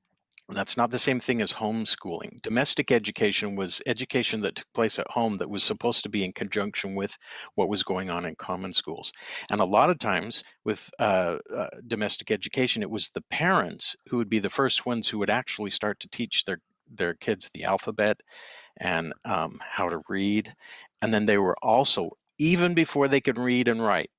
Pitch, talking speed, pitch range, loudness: 115 Hz, 195 wpm, 105-125 Hz, -26 LUFS